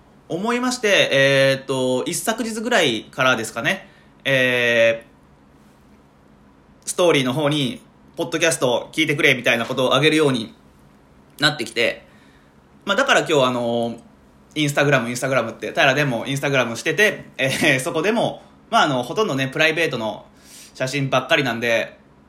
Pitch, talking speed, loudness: 130 Hz, 355 characters per minute, -19 LUFS